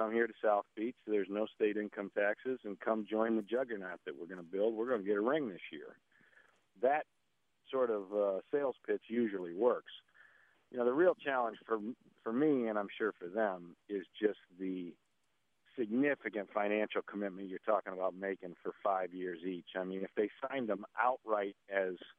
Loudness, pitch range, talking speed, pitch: -37 LUFS, 95-110 Hz, 195 wpm, 105 Hz